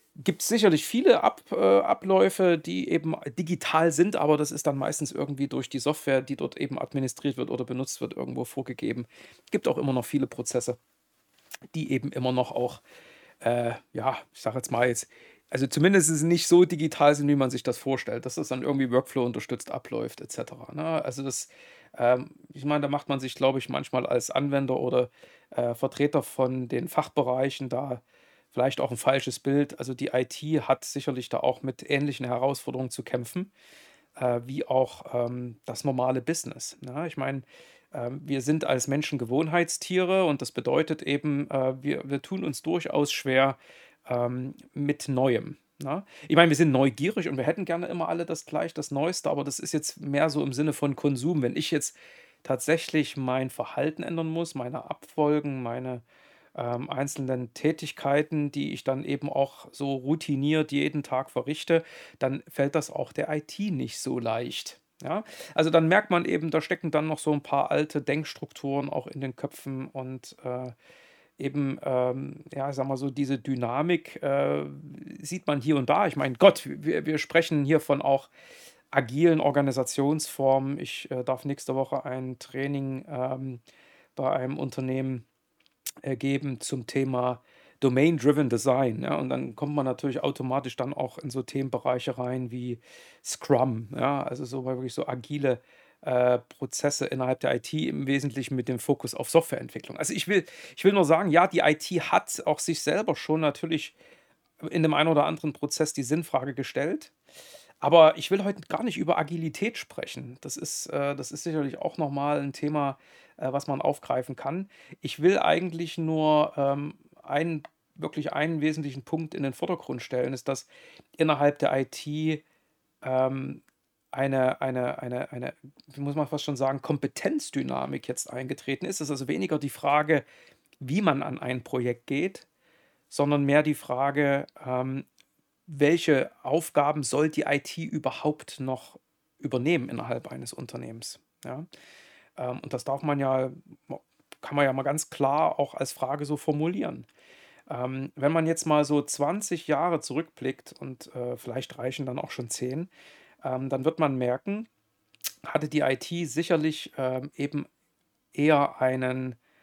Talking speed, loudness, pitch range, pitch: 165 wpm, -28 LUFS, 130-155 Hz, 140 Hz